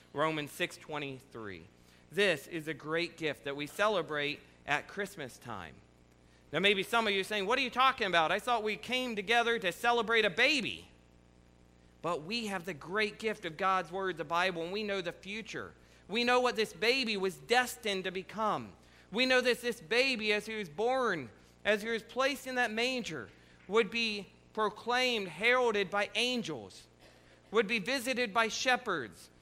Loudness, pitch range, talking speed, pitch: -32 LUFS, 165-235 Hz, 175 wpm, 205 Hz